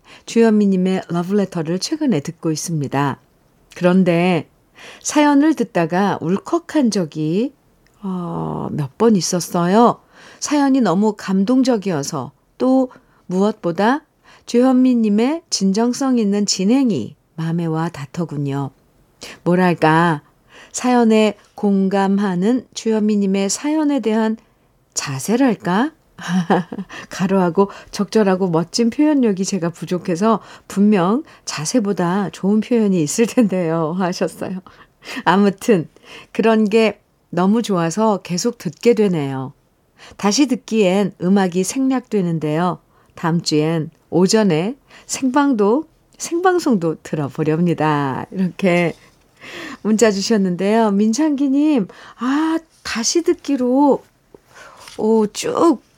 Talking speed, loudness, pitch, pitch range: 230 characters per minute, -18 LUFS, 200 Hz, 170-235 Hz